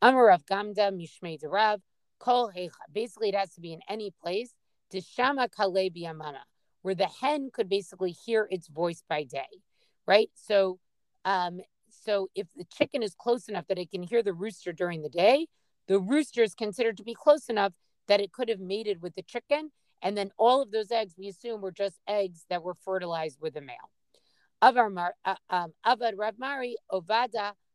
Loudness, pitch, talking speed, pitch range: -29 LUFS, 200 Hz, 160 wpm, 180-230 Hz